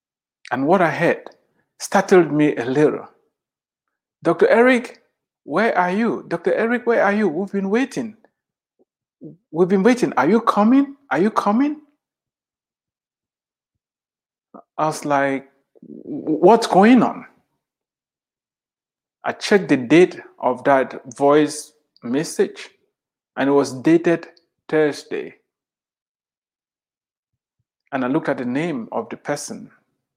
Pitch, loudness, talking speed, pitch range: 190 Hz, -18 LUFS, 115 wpm, 150-240 Hz